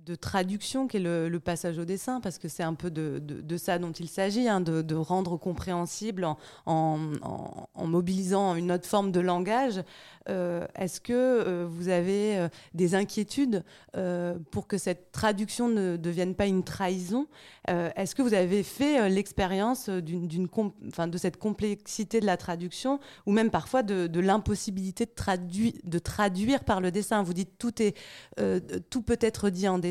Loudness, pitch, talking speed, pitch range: -29 LUFS, 190 Hz, 190 wpm, 175-210 Hz